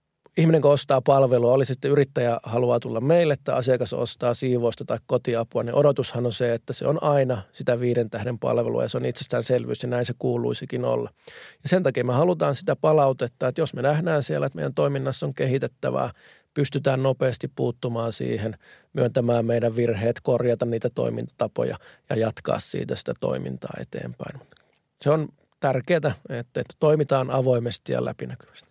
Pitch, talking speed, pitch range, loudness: 125 Hz, 165 wpm, 120-140 Hz, -24 LUFS